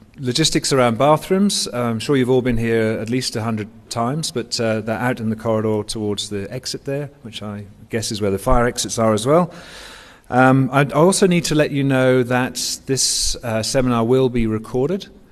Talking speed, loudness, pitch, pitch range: 195 wpm, -18 LUFS, 125 Hz, 110-140 Hz